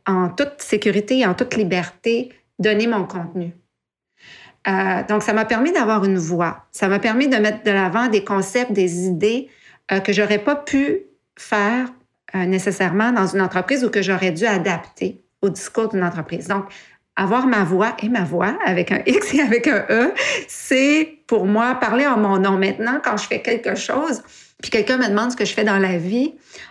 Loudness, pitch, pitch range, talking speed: -19 LUFS, 210 Hz, 190-245 Hz, 195 wpm